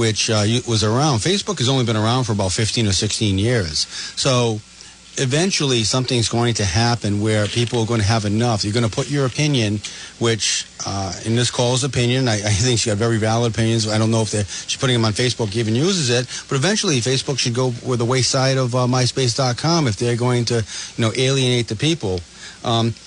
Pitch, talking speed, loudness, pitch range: 120 Hz, 210 wpm, -19 LUFS, 110-130 Hz